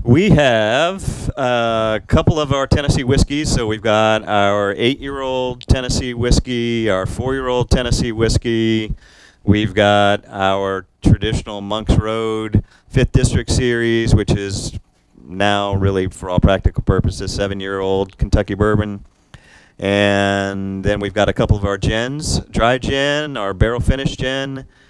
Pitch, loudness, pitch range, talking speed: 110 Hz, -17 LUFS, 100-125 Hz, 130 wpm